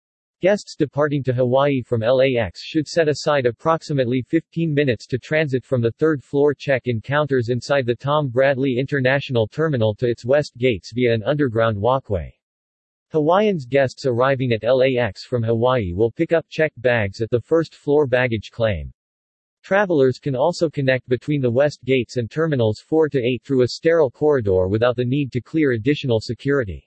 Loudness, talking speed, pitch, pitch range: -20 LUFS, 170 wpm, 130 Hz, 115-145 Hz